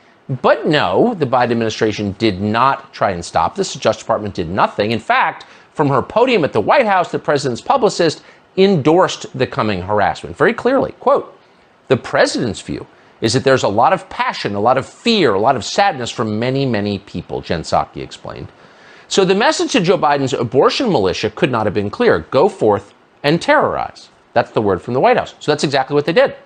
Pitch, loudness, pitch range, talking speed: 135 Hz, -16 LUFS, 110-175 Hz, 205 wpm